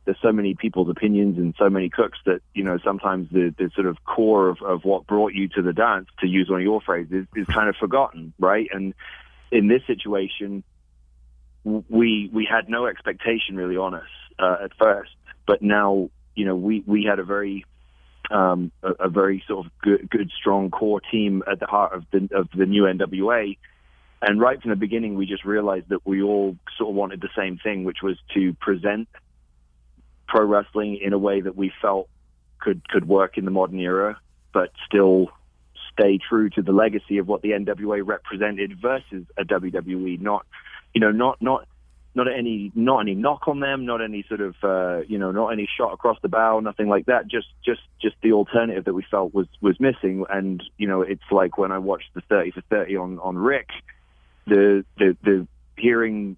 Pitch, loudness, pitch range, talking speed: 100 Hz, -22 LUFS, 95-105 Hz, 205 wpm